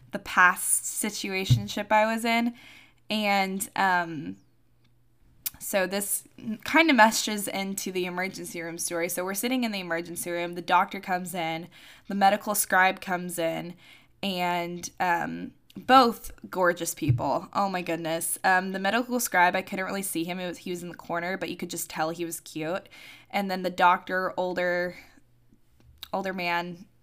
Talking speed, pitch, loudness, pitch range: 160 wpm, 180 Hz, -26 LUFS, 170-195 Hz